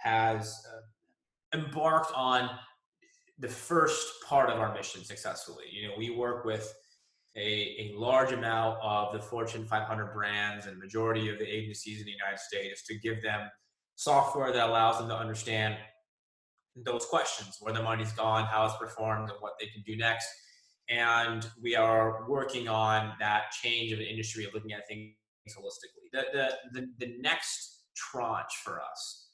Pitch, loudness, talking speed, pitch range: 110 Hz, -32 LUFS, 165 wpm, 110-125 Hz